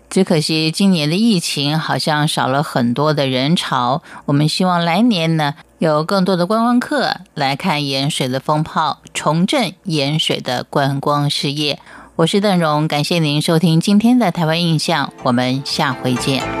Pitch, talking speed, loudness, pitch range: 155 Hz, 245 characters per minute, -16 LUFS, 145-180 Hz